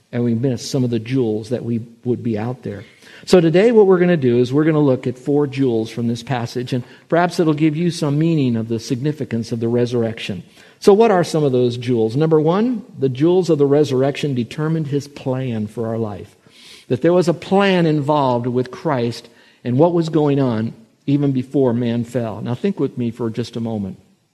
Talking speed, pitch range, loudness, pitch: 220 wpm, 120-160 Hz, -18 LUFS, 130 Hz